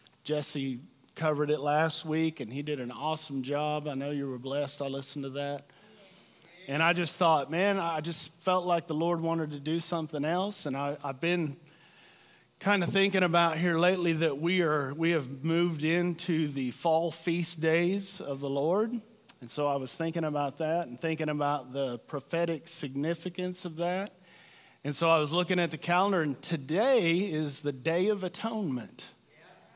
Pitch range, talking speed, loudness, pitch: 145-175 Hz, 180 wpm, -30 LUFS, 160 Hz